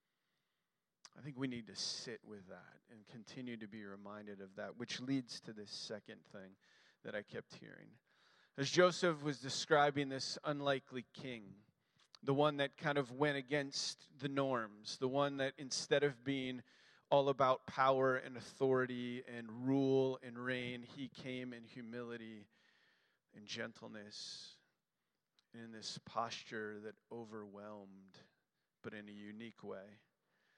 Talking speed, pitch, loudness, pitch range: 140 wpm, 125 Hz, -40 LUFS, 110-140 Hz